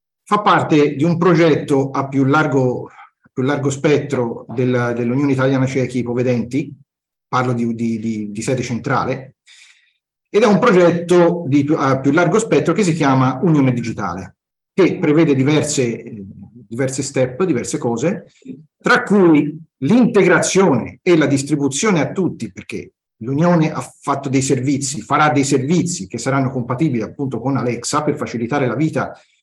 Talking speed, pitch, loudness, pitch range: 135 wpm, 140 Hz, -16 LUFS, 125-160 Hz